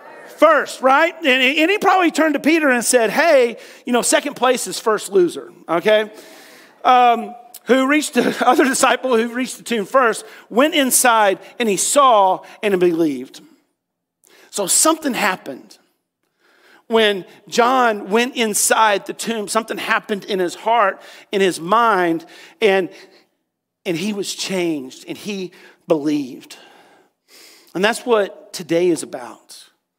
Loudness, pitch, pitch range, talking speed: -17 LUFS, 235 Hz, 200-285 Hz, 140 wpm